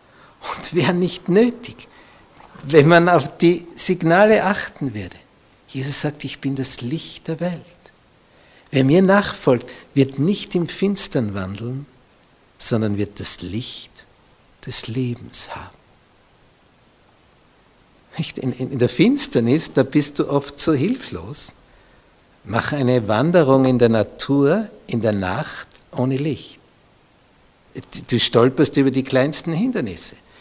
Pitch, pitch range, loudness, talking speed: 140 Hz, 125-170 Hz, -18 LUFS, 115 wpm